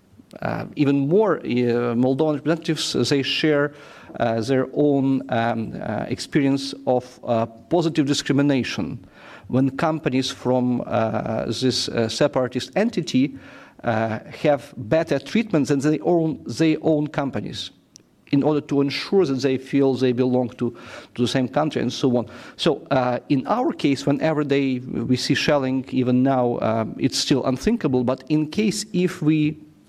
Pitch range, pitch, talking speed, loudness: 125-155 Hz, 140 Hz, 150 wpm, -22 LUFS